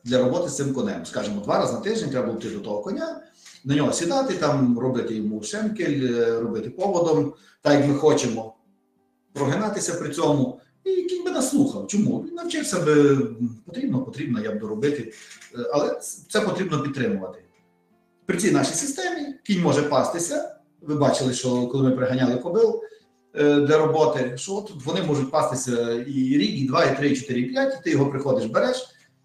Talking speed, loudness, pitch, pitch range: 170 wpm, -23 LUFS, 150 Hz, 130-210 Hz